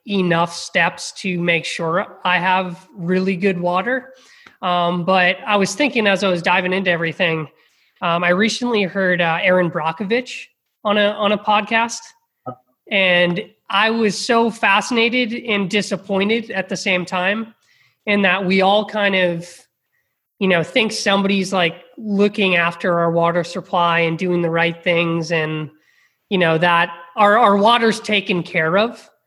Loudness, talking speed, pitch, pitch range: -17 LUFS, 155 wpm, 190 Hz, 175-210 Hz